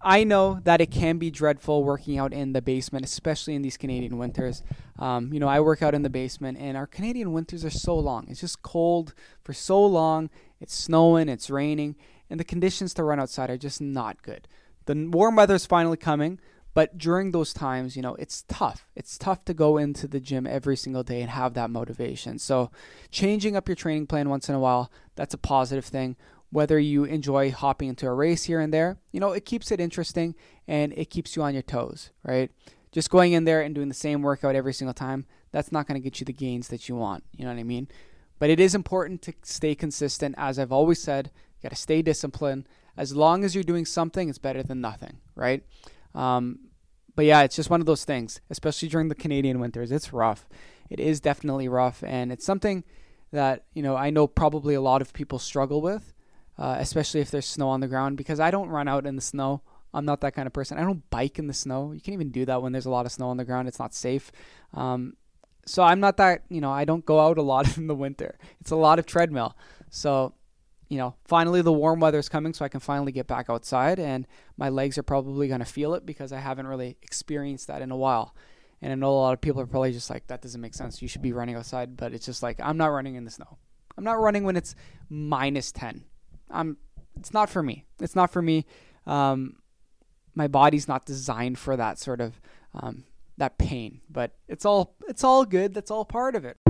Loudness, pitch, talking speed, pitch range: -26 LUFS, 145 Hz, 235 wpm, 130-160 Hz